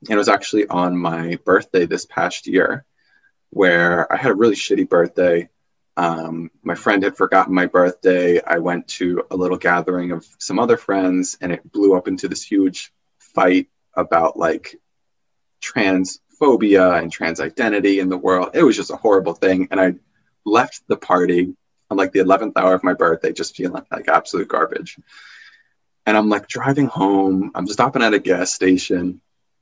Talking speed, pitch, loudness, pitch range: 175 wpm, 90 Hz, -18 LUFS, 90-95 Hz